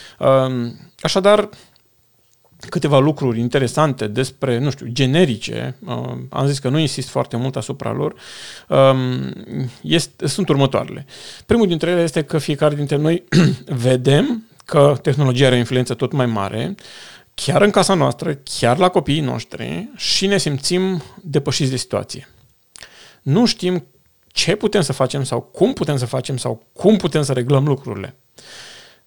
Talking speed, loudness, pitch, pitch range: 140 wpm, -18 LUFS, 140 Hz, 130-165 Hz